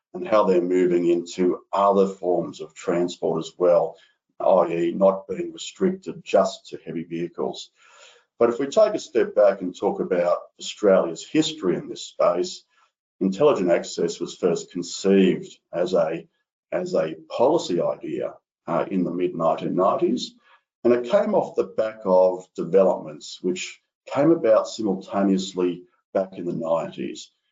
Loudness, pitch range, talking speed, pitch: -23 LUFS, 85-120 Hz, 145 wpm, 95 Hz